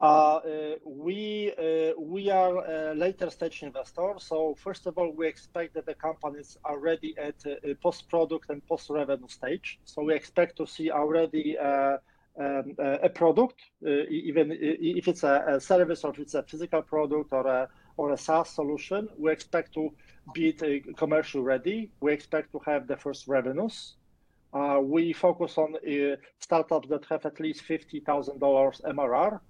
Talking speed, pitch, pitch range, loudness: 175 wpm, 155 Hz, 145-165 Hz, -29 LUFS